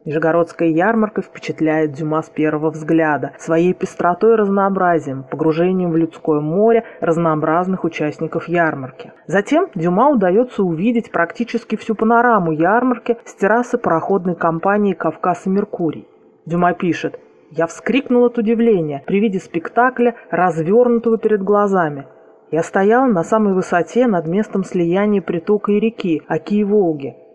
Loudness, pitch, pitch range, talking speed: -17 LUFS, 180 Hz, 165-220 Hz, 125 wpm